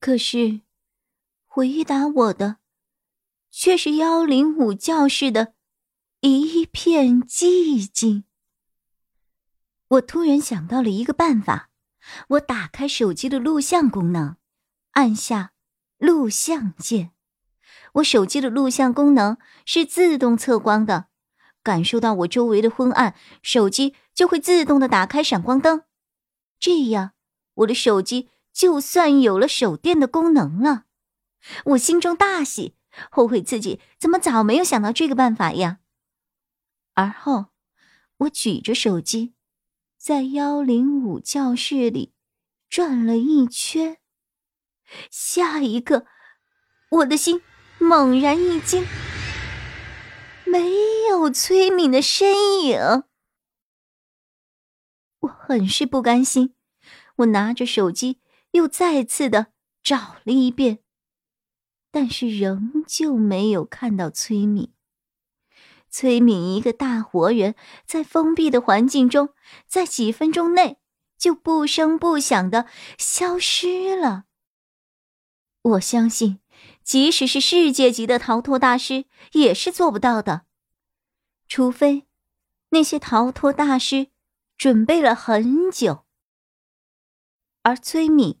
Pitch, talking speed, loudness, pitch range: 265 Hz, 165 characters per minute, -19 LUFS, 225-310 Hz